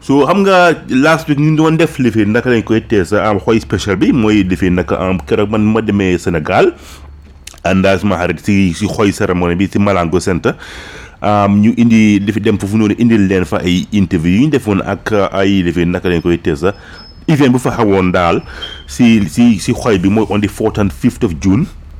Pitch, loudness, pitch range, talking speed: 100 Hz, -12 LUFS, 90-115 Hz, 200 wpm